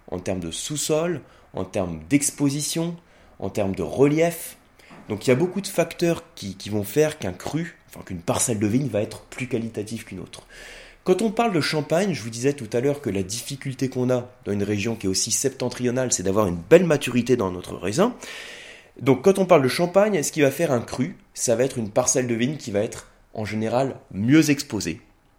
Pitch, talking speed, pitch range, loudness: 125 Hz, 215 wpm, 105-150 Hz, -23 LUFS